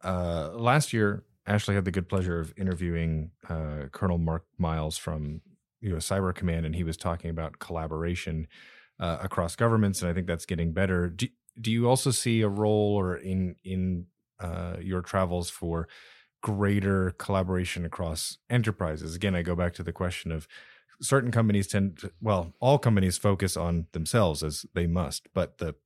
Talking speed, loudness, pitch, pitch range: 175 wpm, -29 LUFS, 90 Hz, 85-100 Hz